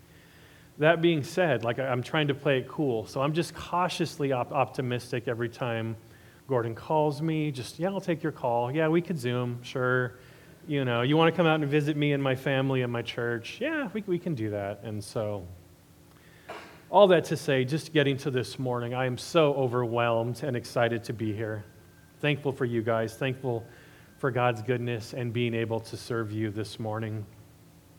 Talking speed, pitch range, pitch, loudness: 195 wpm, 115-150 Hz, 125 Hz, -28 LUFS